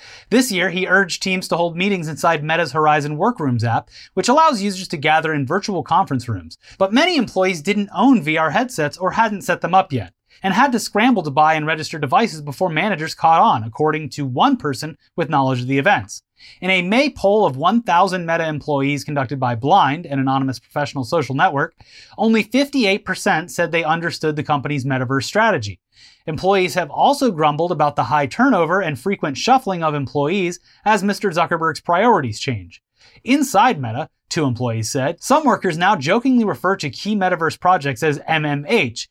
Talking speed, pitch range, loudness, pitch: 180 wpm, 145-195 Hz, -18 LUFS, 165 Hz